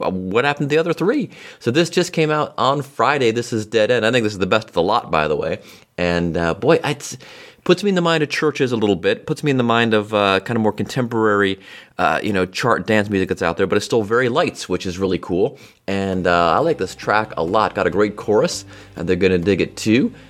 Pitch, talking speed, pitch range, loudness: 105 Hz, 265 wpm, 95-140 Hz, -18 LUFS